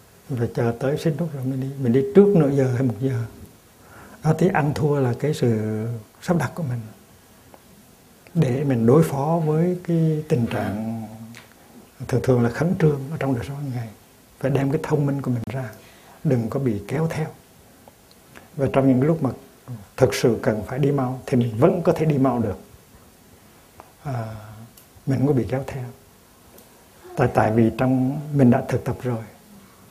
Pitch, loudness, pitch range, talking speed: 130 Hz, -22 LUFS, 120-145 Hz, 190 wpm